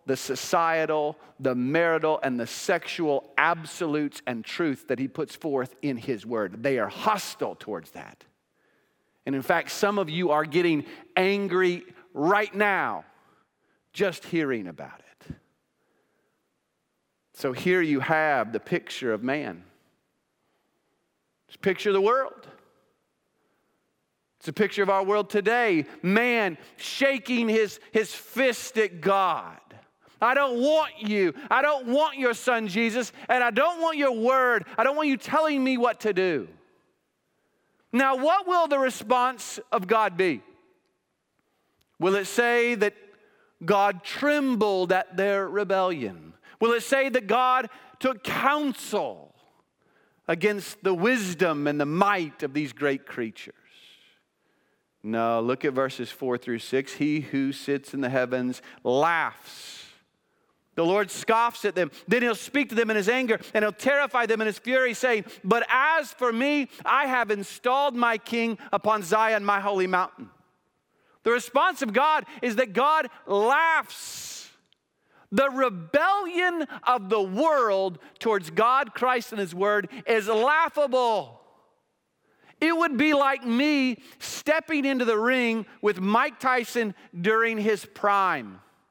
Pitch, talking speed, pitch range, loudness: 220 Hz, 140 wpm, 185-255 Hz, -25 LUFS